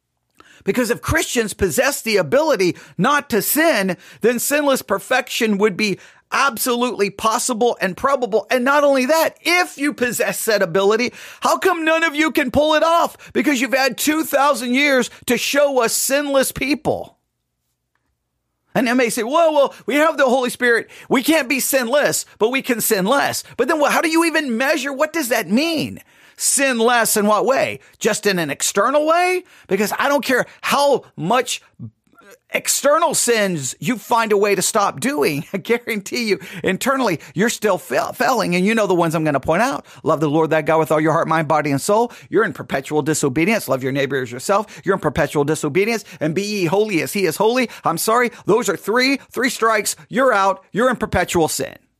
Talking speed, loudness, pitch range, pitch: 195 wpm, -18 LUFS, 190-275 Hz, 230 Hz